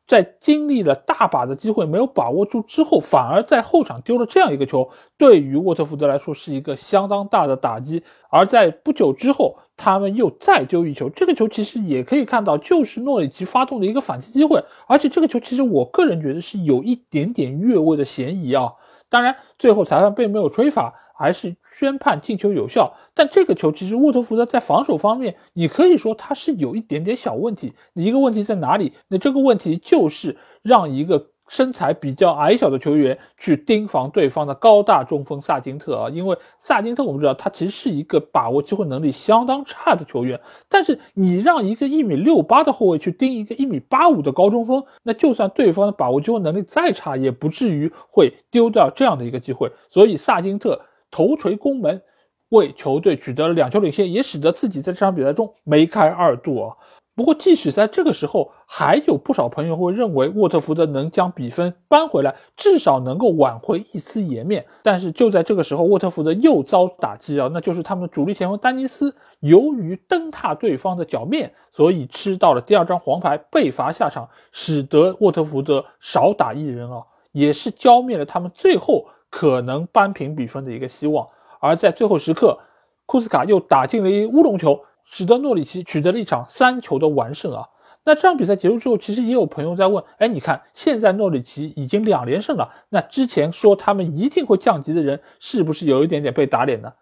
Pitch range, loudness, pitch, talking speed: 155-255 Hz, -18 LUFS, 200 Hz, 320 characters per minute